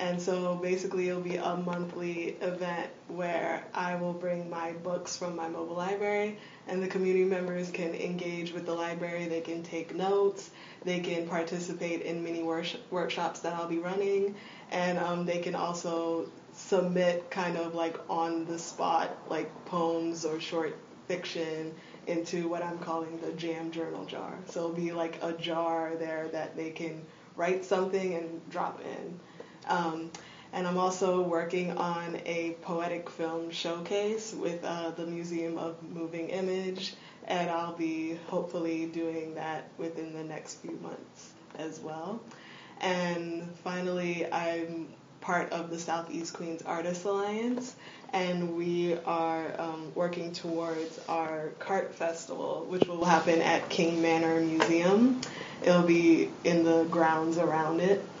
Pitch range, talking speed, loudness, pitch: 165-180 Hz, 150 wpm, -32 LUFS, 170 Hz